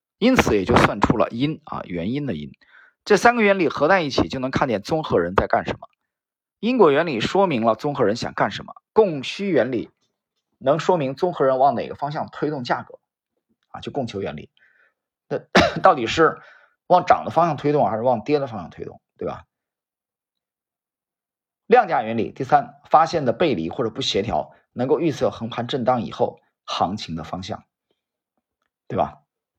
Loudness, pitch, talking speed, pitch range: -21 LUFS, 145 Hz, 260 characters per minute, 120-195 Hz